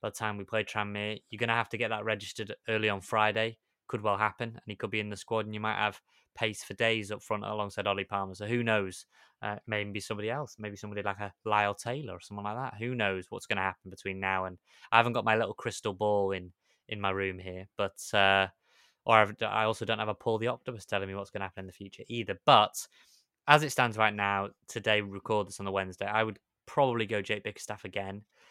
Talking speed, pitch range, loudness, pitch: 250 wpm, 100-110 Hz, -31 LUFS, 105 Hz